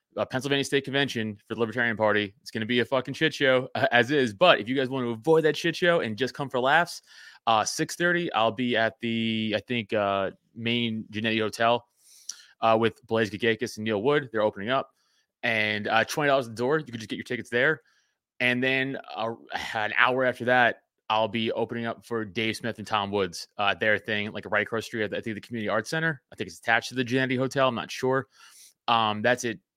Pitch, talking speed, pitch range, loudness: 115 Hz, 230 wpm, 110-130 Hz, -26 LUFS